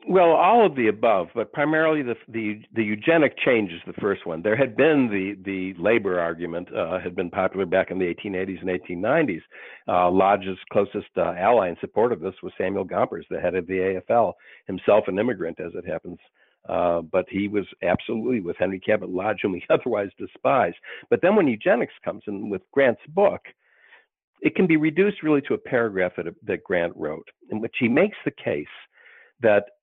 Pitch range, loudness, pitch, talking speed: 95-145 Hz, -23 LUFS, 100 Hz, 195 wpm